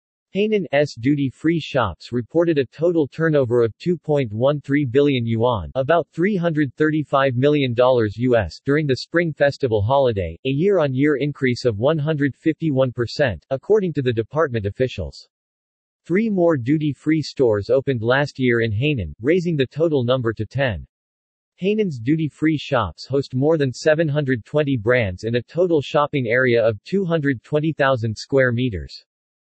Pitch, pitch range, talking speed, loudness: 140 Hz, 120-155 Hz, 130 wpm, -20 LUFS